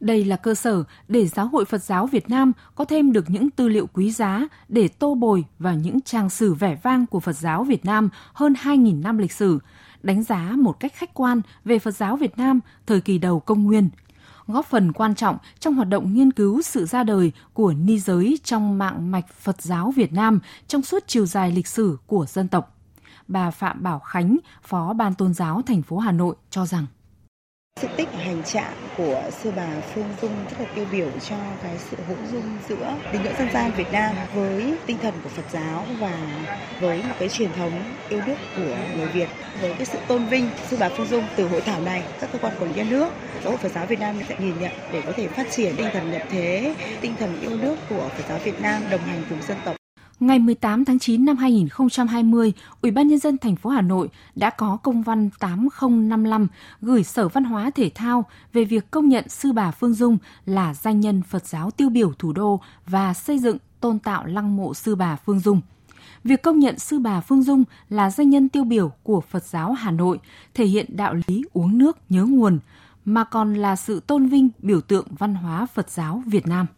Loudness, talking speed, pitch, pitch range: -22 LUFS, 225 wpm, 210 Hz, 185-240 Hz